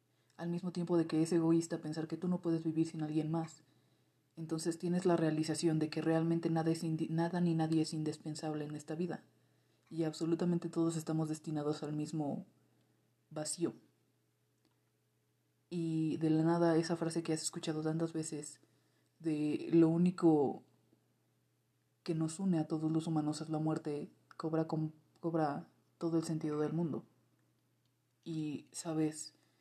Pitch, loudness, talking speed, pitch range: 160 Hz, -36 LUFS, 155 wpm, 155-165 Hz